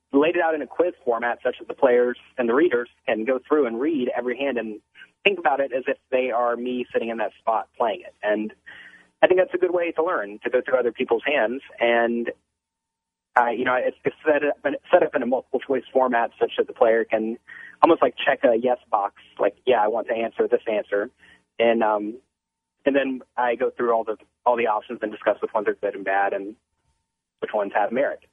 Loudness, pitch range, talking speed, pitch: -23 LUFS, 110-140 Hz, 235 wpm, 120 Hz